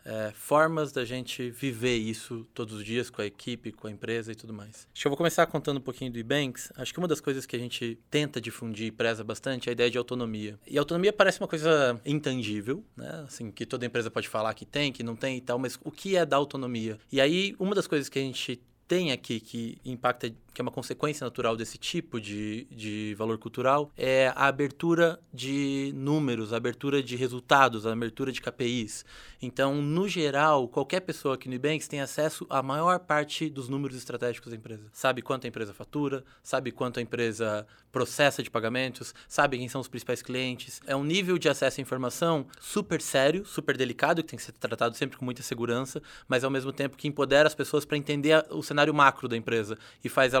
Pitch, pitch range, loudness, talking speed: 130 Hz, 120-145 Hz, -29 LUFS, 215 wpm